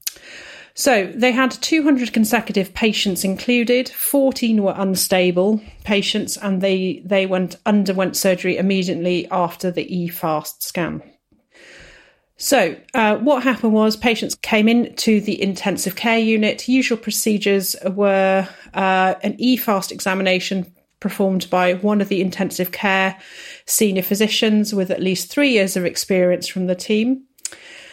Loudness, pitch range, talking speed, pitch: -18 LUFS, 185-225 Hz, 135 wpm, 195 Hz